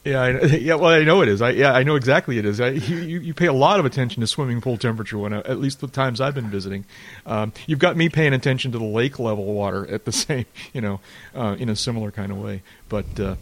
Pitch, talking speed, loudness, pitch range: 120 Hz, 270 wpm, -21 LUFS, 105-140 Hz